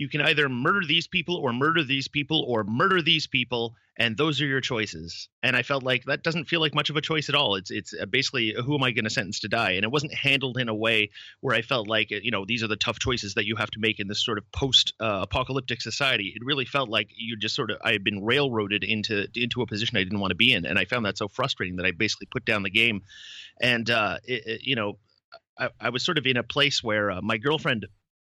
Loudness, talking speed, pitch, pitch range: -25 LUFS, 270 wpm, 120 Hz, 105-140 Hz